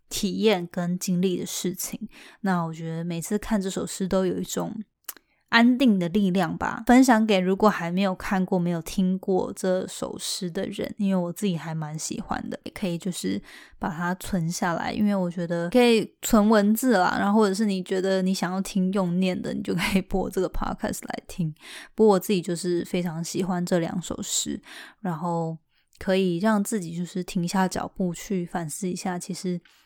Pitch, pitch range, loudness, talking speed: 185 Hz, 175-205 Hz, -25 LUFS, 290 characters per minute